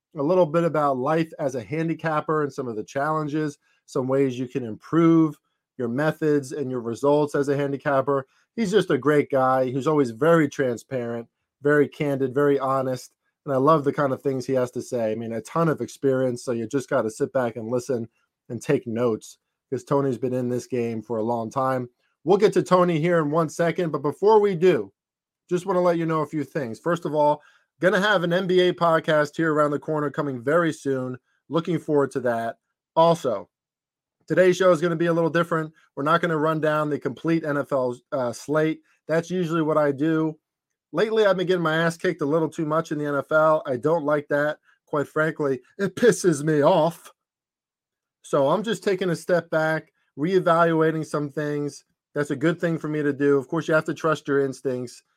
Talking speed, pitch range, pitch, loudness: 210 wpm, 135-165 Hz, 150 Hz, -23 LUFS